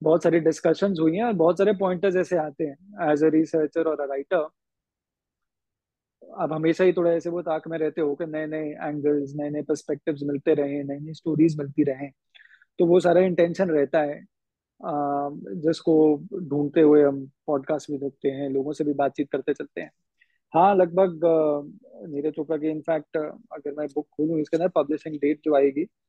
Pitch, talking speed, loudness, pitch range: 155 Hz, 175 wpm, -24 LUFS, 145-165 Hz